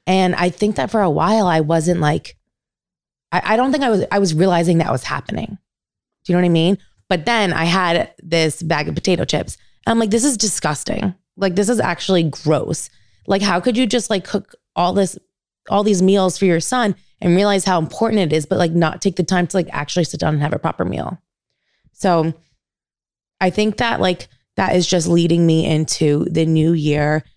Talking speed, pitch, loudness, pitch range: 215 wpm, 175 Hz, -17 LUFS, 160-195 Hz